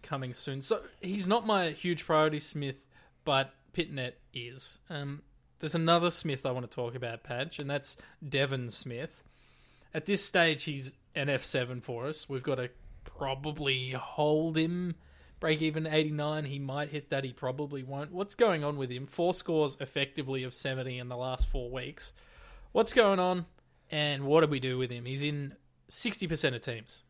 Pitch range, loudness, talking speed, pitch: 130-160 Hz, -32 LUFS, 175 wpm, 145 Hz